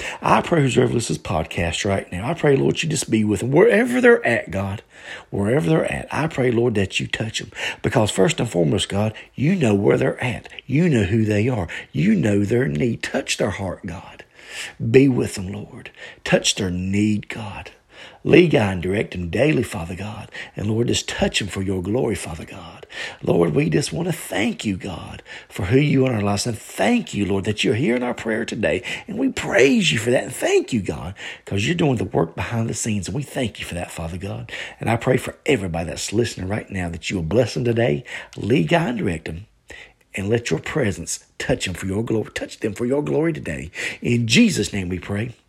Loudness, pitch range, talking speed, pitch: -21 LUFS, 95-125 Hz, 225 wpm, 110 Hz